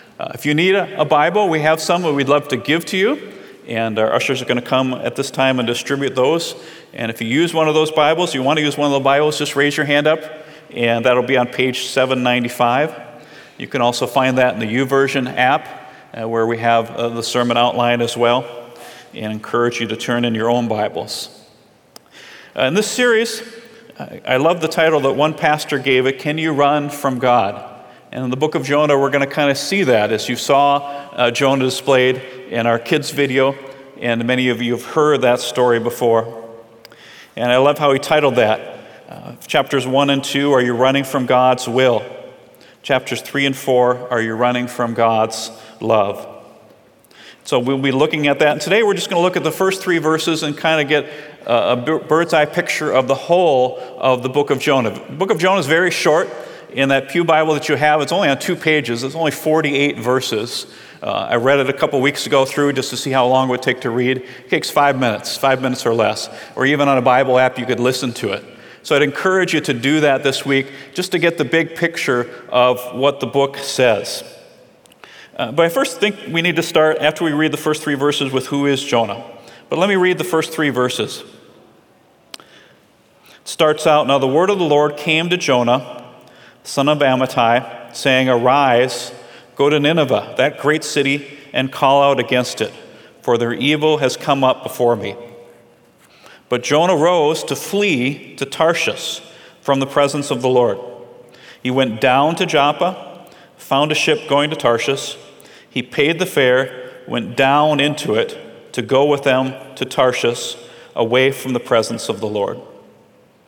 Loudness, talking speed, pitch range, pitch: -16 LUFS, 205 wpm, 125-155 Hz, 140 Hz